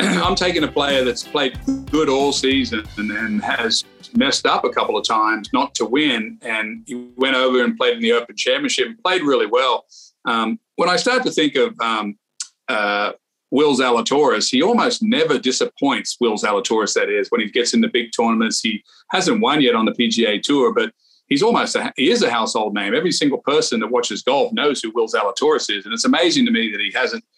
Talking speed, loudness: 215 wpm, -18 LUFS